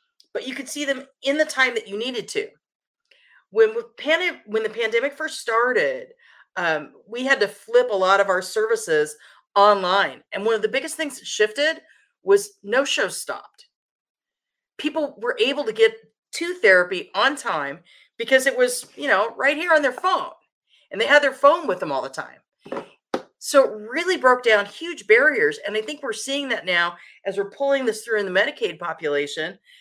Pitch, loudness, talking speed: 280 Hz, -21 LUFS, 185 wpm